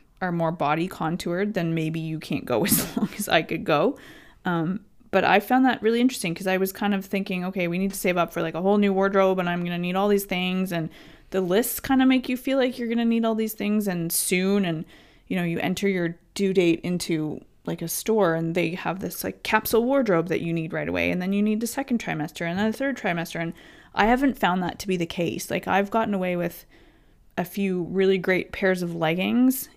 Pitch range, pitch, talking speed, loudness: 170-215 Hz, 190 Hz, 245 wpm, -24 LUFS